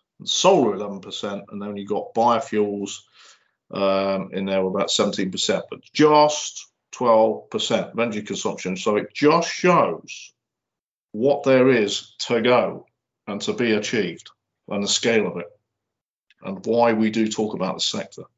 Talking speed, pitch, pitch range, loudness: 155 wpm, 105 Hz, 100-115 Hz, -21 LUFS